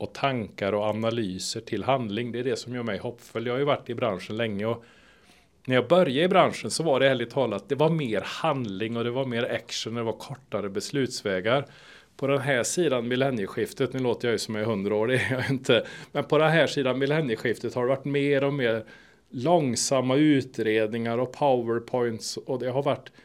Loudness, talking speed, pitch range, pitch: -26 LUFS, 210 wpm, 115-135 Hz, 125 Hz